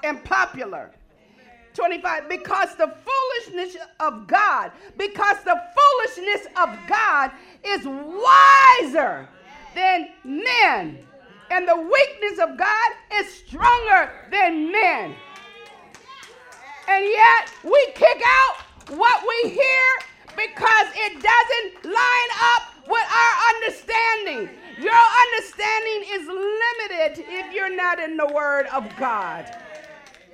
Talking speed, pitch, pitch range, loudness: 105 wpm, 375 Hz, 310-435 Hz, -18 LUFS